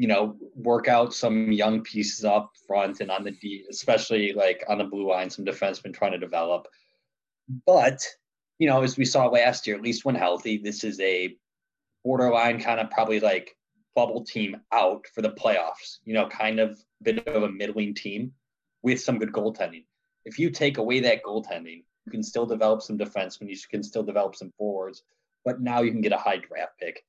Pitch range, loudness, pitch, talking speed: 105-125 Hz, -26 LUFS, 110 Hz, 200 wpm